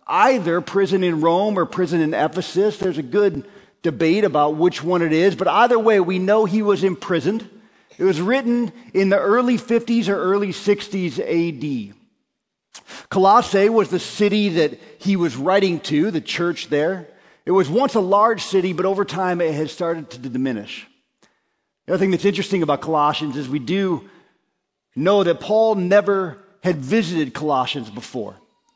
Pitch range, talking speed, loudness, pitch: 165-205 Hz, 165 wpm, -19 LUFS, 190 Hz